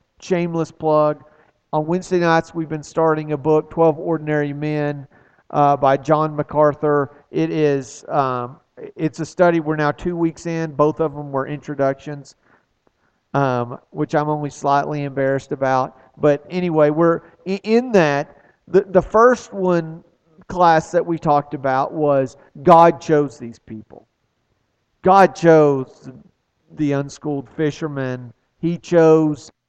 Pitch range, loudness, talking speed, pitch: 140-165 Hz, -18 LUFS, 135 wpm, 150 Hz